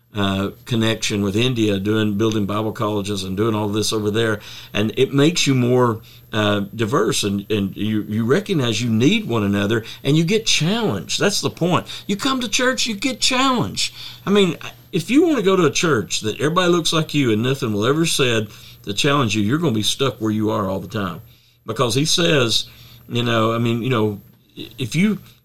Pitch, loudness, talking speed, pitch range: 120 Hz, -19 LUFS, 210 wpm, 105-150 Hz